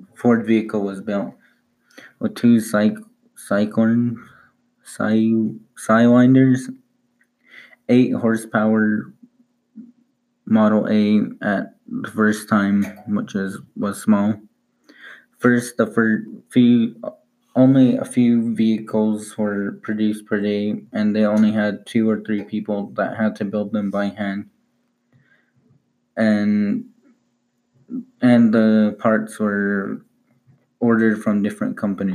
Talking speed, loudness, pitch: 110 wpm, -19 LUFS, 115 Hz